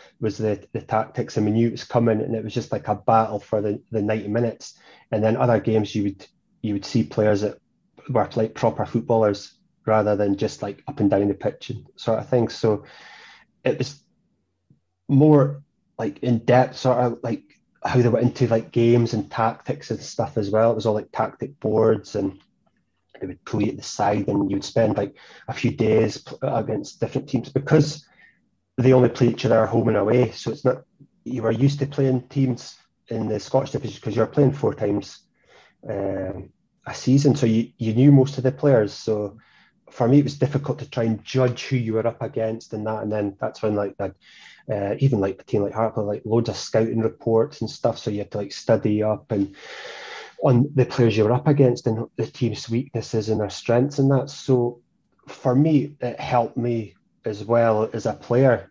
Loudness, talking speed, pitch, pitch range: -22 LUFS, 210 wpm, 115 Hz, 110-130 Hz